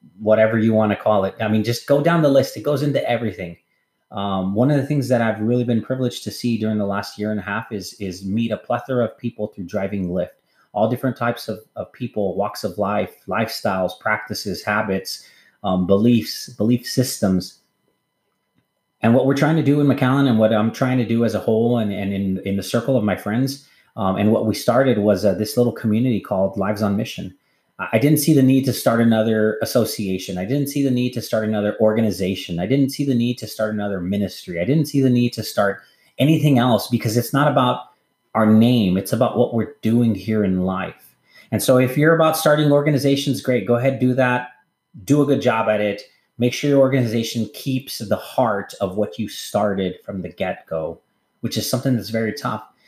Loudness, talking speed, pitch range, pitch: -20 LUFS, 215 wpm, 105-130 Hz, 115 Hz